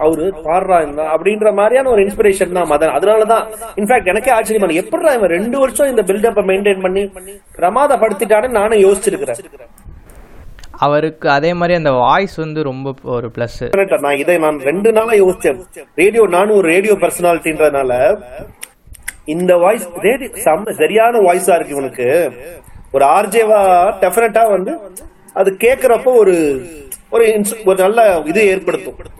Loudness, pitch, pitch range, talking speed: -13 LUFS, 195 Hz, 165-225 Hz, 130 wpm